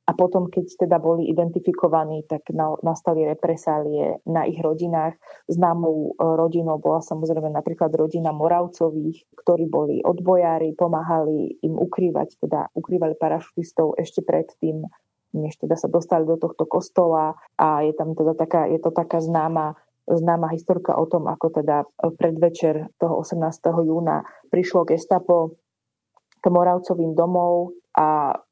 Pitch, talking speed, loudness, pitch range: 165 Hz, 135 wpm, -22 LUFS, 160-175 Hz